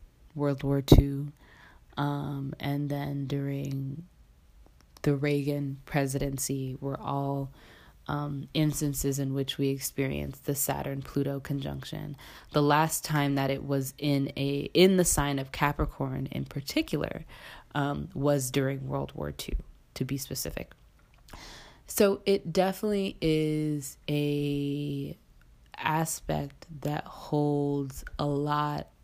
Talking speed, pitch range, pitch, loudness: 115 wpm, 135-145 Hz, 140 Hz, -30 LUFS